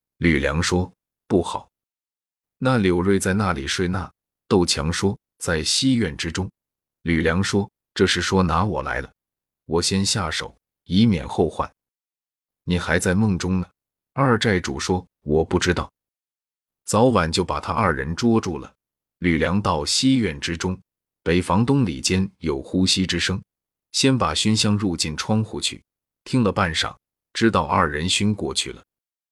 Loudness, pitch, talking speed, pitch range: -21 LUFS, 90 Hz, 210 characters per minute, 80-100 Hz